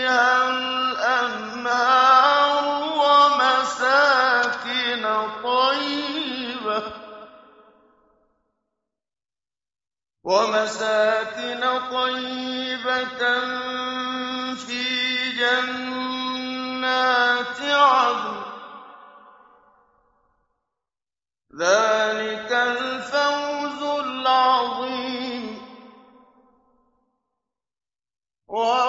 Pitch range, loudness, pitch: 245-255 Hz, -21 LUFS, 255 Hz